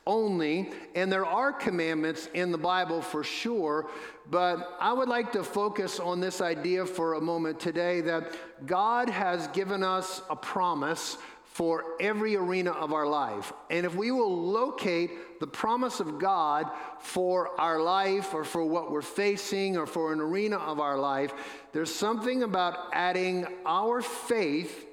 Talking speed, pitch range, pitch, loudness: 160 wpm, 160-195 Hz, 175 Hz, -30 LUFS